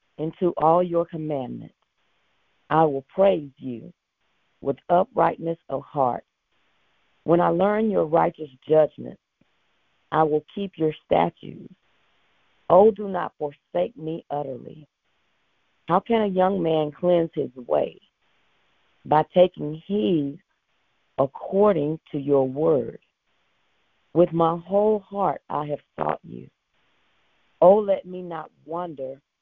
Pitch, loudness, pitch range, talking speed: 165 Hz, -23 LUFS, 150-180 Hz, 115 wpm